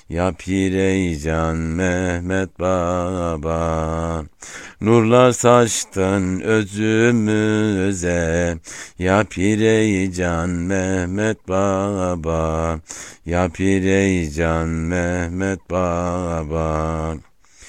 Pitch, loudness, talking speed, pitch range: 90 Hz, -19 LUFS, 50 wpm, 80-95 Hz